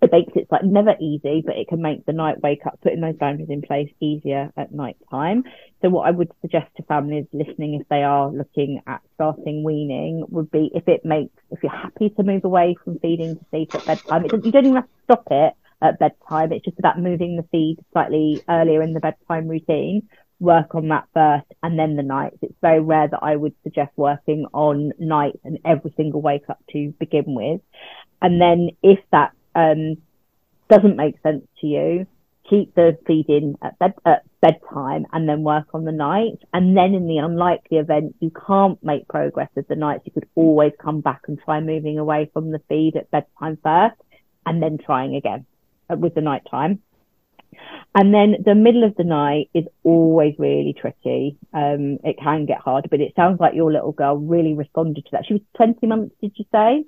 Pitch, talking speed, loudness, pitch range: 155 Hz, 205 wpm, -19 LUFS, 150-175 Hz